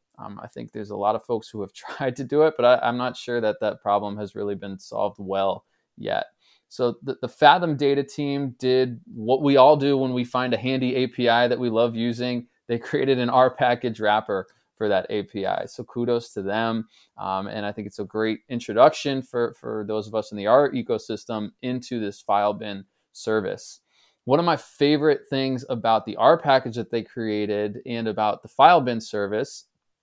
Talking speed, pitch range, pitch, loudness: 200 wpm, 105-130 Hz, 120 Hz, -23 LUFS